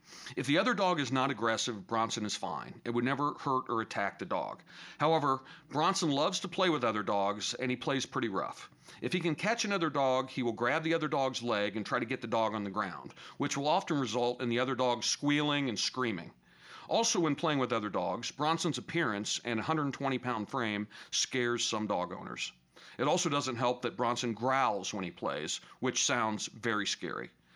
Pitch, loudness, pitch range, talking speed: 130 Hz, -32 LUFS, 115-150 Hz, 205 wpm